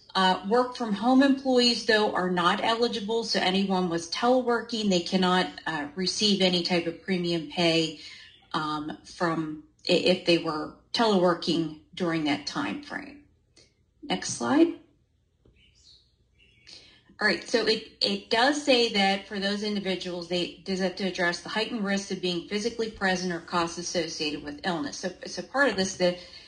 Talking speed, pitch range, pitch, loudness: 155 wpm, 175-225 Hz, 185 Hz, -26 LUFS